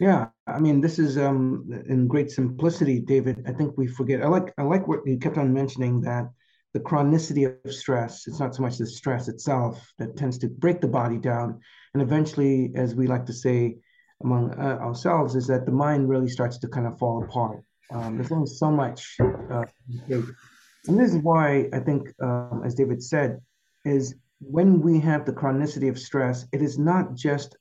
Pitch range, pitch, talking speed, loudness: 125-145 Hz, 135 Hz, 200 wpm, -25 LUFS